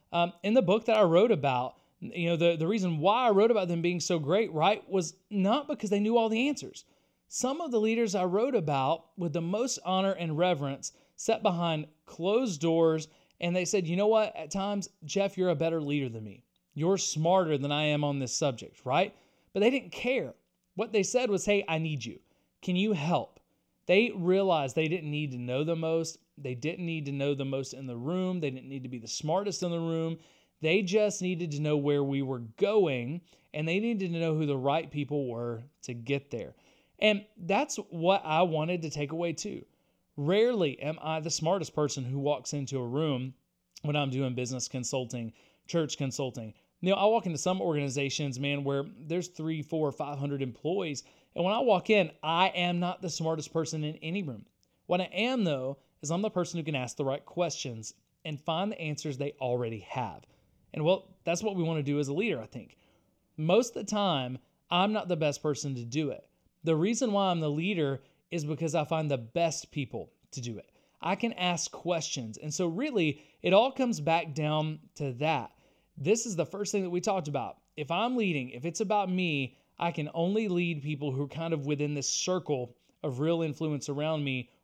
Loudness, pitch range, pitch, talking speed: -30 LUFS, 145-190 Hz, 165 Hz, 215 wpm